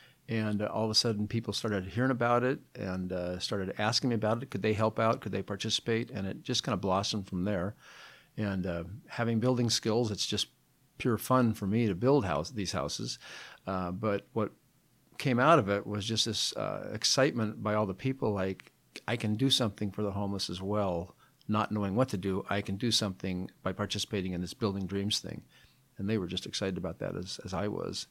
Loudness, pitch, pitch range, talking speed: -31 LUFS, 105 Hz, 95-115 Hz, 215 wpm